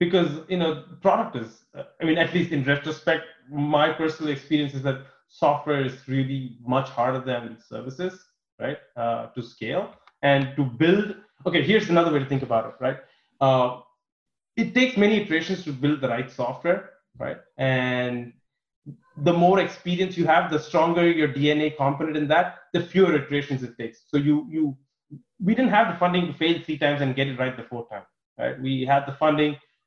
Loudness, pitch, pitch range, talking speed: -24 LUFS, 150 Hz, 130-170 Hz, 185 wpm